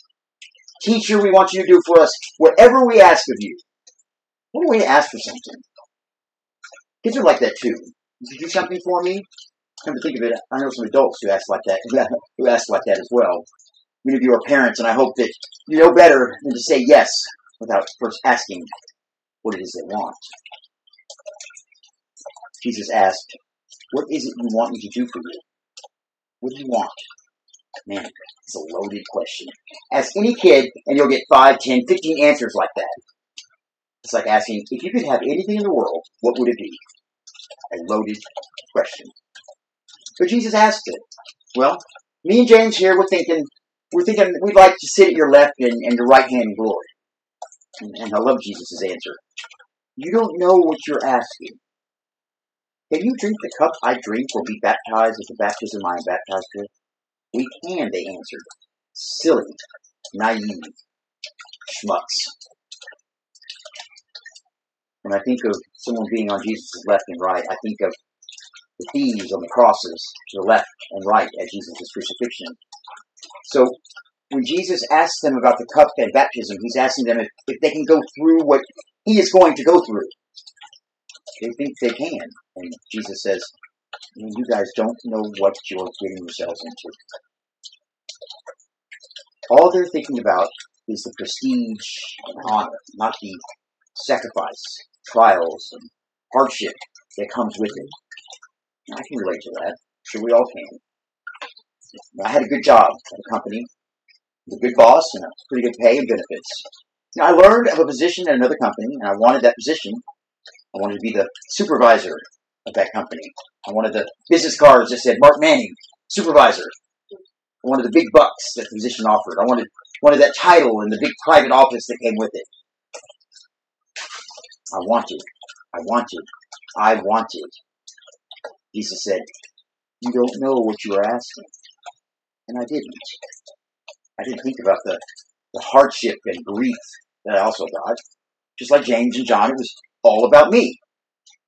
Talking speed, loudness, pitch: 170 wpm, -17 LUFS, 175 Hz